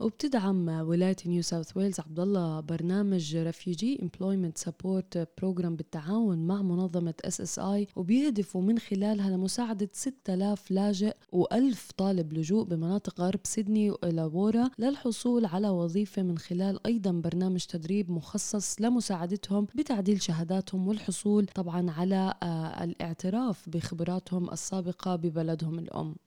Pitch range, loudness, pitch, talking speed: 175-205 Hz, -30 LUFS, 190 Hz, 115 wpm